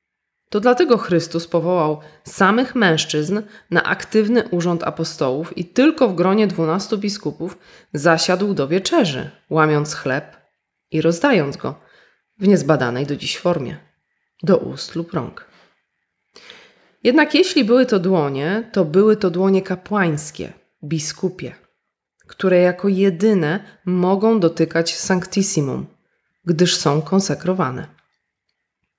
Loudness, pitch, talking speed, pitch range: -18 LUFS, 180 Hz, 110 wpm, 160-205 Hz